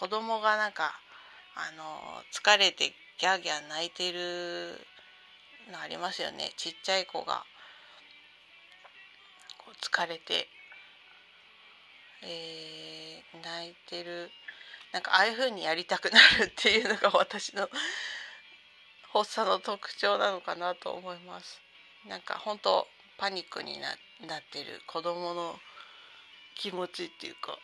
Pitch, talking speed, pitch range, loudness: 180 Hz, 235 characters per minute, 170-215 Hz, -29 LUFS